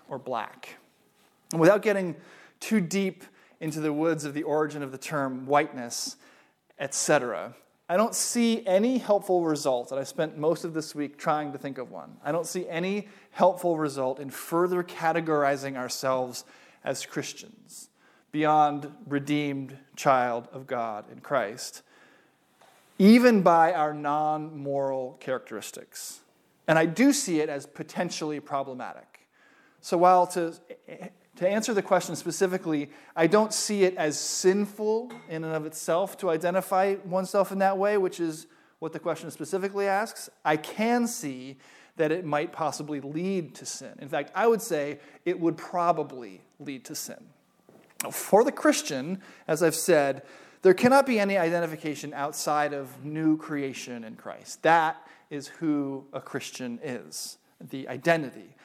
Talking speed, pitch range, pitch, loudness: 150 wpm, 145-190 Hz, 160 Hz, -27 LUFS